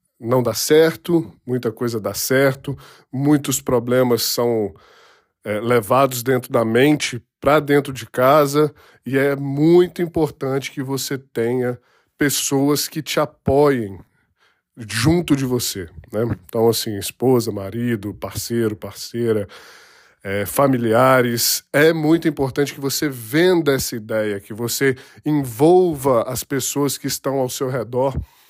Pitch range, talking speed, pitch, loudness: 115-145 Hz, 125 wpm, 130 Hz, -19 LUFS